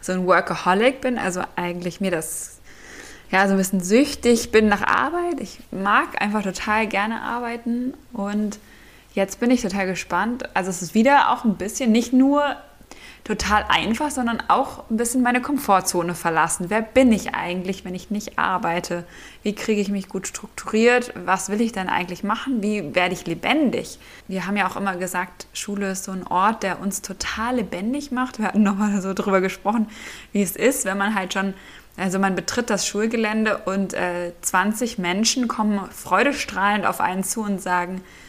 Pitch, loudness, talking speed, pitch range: 205 Hz, -22 LUFS, 180 wpm, 190-235 Hz